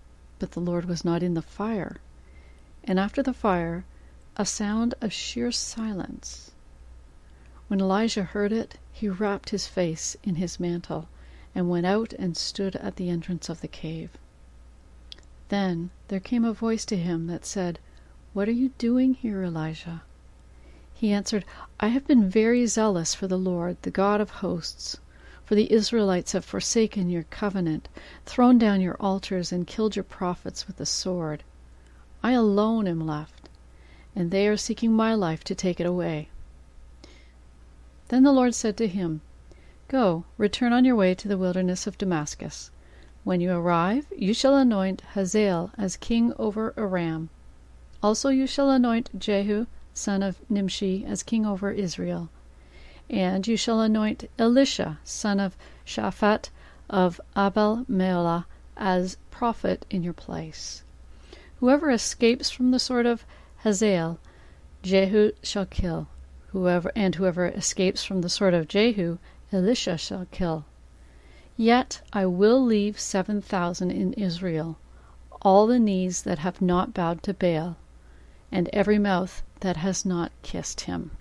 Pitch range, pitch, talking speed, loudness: 160-215 Hz, 185 Hz, 150 wpm, -25 LUFS